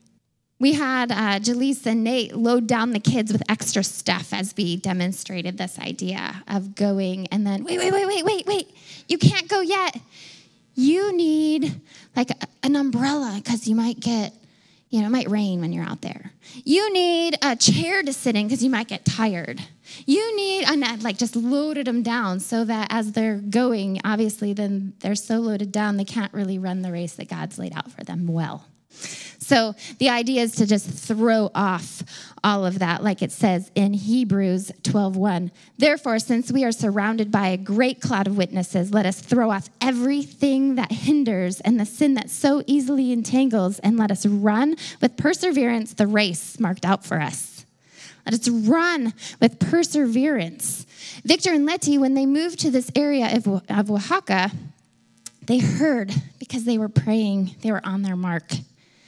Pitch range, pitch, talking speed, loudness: 195-265 Hz, 225 Hz, 180 wpm, -22 LUFS